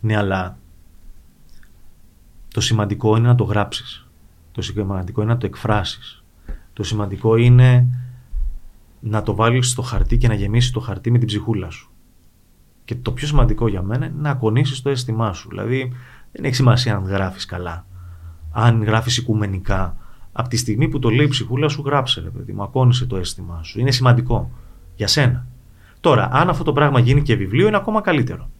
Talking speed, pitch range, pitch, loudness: 180 wpm, 95-125 Hz, 110 Hz, -18 LUFS